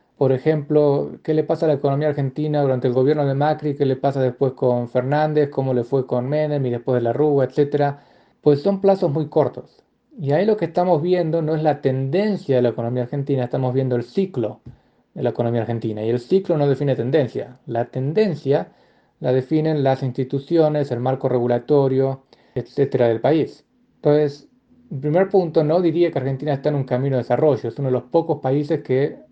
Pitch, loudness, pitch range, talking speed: 140 Hz, -20 LUFS, 130-155 Hz, 195 wpm